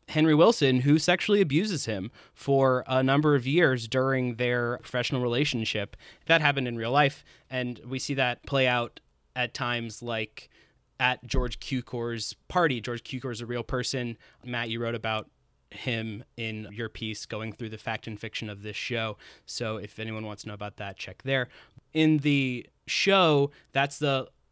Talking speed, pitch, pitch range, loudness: 175 wpm, 125 Hz, 115-135 Hz, -27 LUFS